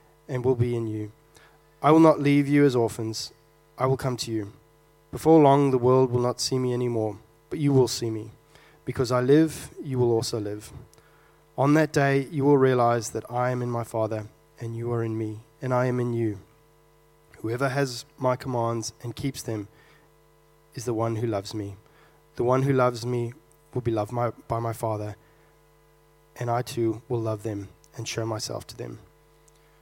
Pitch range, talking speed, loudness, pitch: 115-140 Hz, 190 wpm, -25 LUFS, 120 Hz